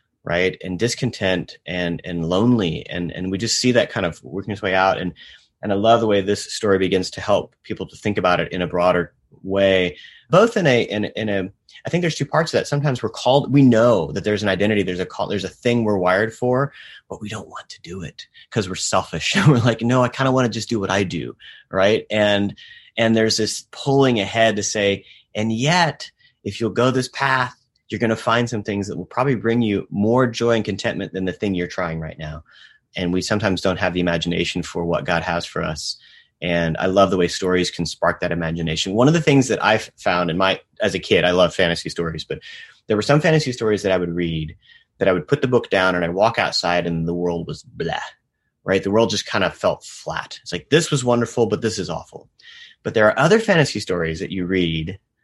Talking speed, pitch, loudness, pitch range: 240 wpm, 100 Hz, -20 LUFS, 90-120 Hz